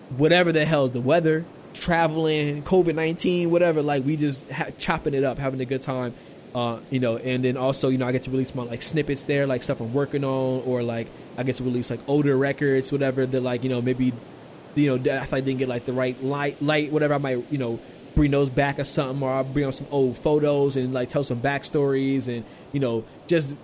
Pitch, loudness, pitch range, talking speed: 135 Hz, -24 LUFS, 130-145 Hz, 240 wpm